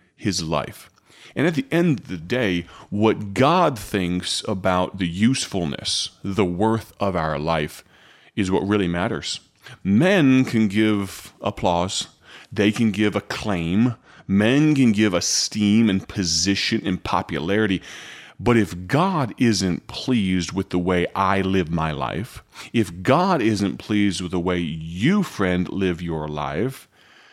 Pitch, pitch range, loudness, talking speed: 100 Hz, 90-115 Hz, -21 LUFS, 140 wpm